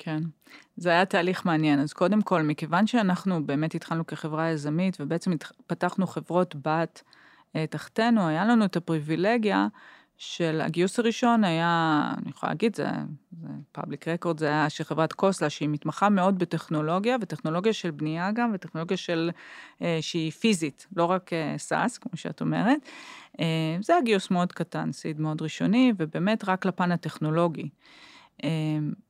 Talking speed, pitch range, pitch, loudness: 155 wpm, 155-190 Hz, 170 Hz, -27 LUFS